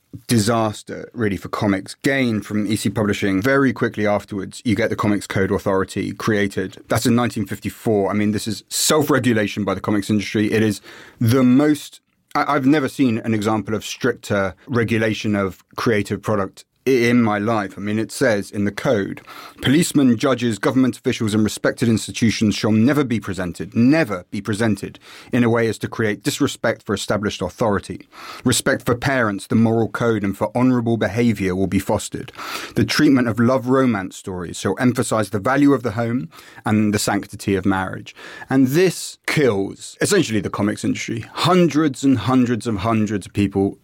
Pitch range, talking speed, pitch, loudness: 105-125 Hz, 170 wpm, 110 Hz, -19 LUFS